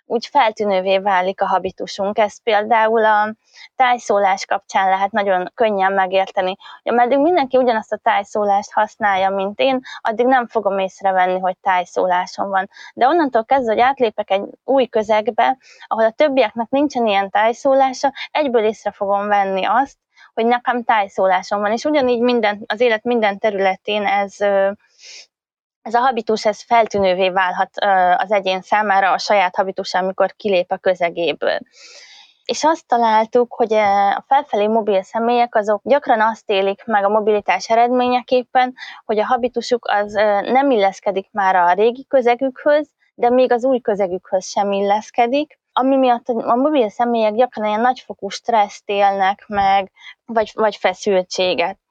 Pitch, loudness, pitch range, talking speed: 215 Hz, -17 LUFS, 195-245 Hz, 140 wpm